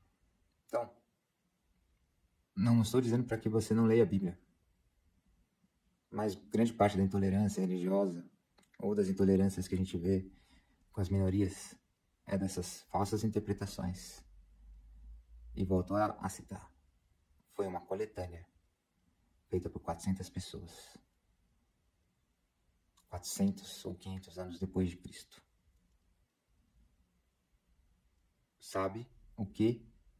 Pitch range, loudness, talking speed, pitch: 85-100 Hz, -35 LUFS, 105 wpm, 90 Hz